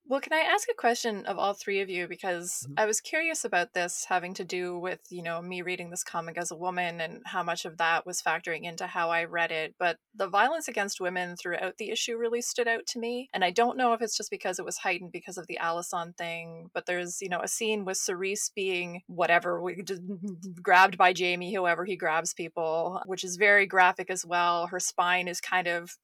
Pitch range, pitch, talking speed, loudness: 175-200 Hz, 180 Hz, 235 wpm, -29 LUFS